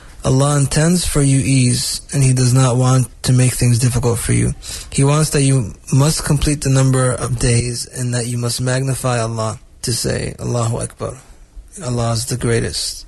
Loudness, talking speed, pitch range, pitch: -16 LUFS, 185 wpm, 120-135 Hz, 125 Hz